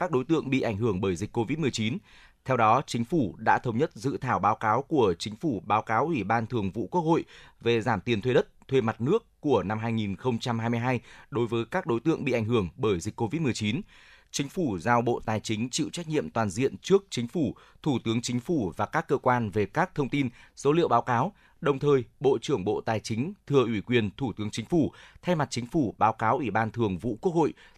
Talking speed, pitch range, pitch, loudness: 235 wpm, 115-140 Hz, 120 Hz, -28 LUFS